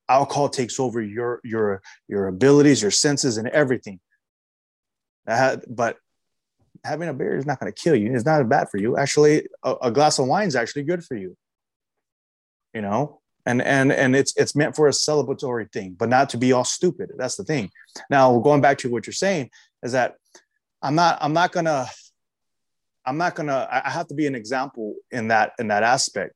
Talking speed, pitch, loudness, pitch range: 205 wpm, 135 Hz, -21 LUFS, 120-150 Hz